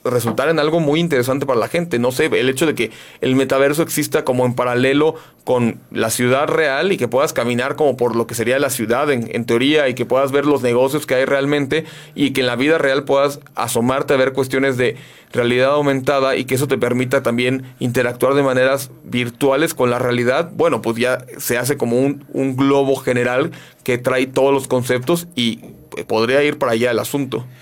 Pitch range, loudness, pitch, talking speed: 125-140 Hz, -17 LUFS, 130 Hz, 210 wpm